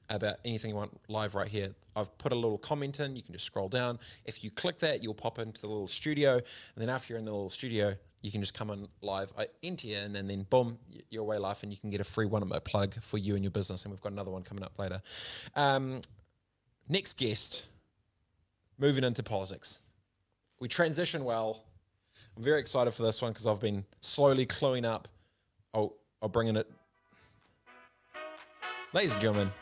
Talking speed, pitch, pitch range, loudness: 215 wpm, 105 Hz, 100-120 Hz, -34 LUFS